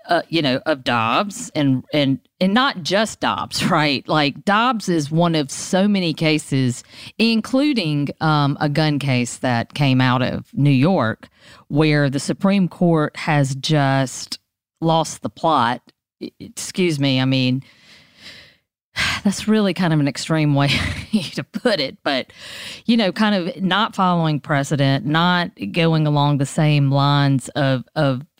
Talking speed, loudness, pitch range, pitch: 150 wpm, -19 LUFS, 135-180 Hz, 150 Hz